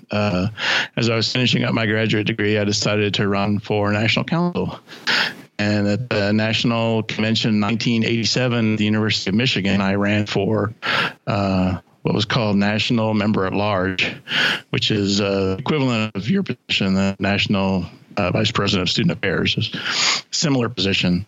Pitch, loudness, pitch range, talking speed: 105 Hz, -19 LUFS, 100-115 Hz, 160 wpm